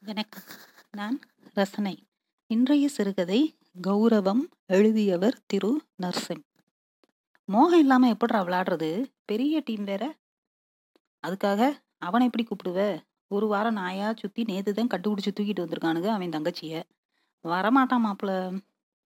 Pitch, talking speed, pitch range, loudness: 210 Hz, 105 wpm, 190-240 Hz, -26 LUFS